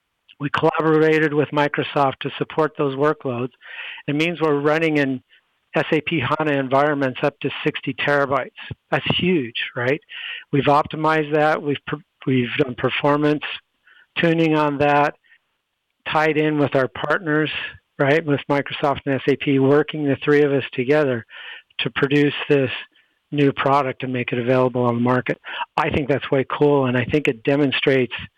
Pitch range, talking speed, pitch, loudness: 135-150 Hz, 150 wpm, 145 Hz, -20 LUFS